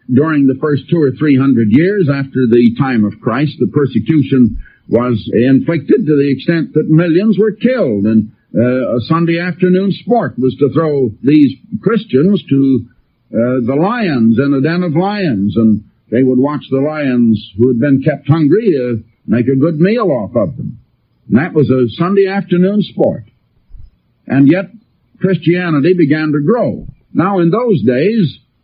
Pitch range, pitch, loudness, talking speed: 125-175 Hz, 145 Hz, -12 LUFS, 170 wpm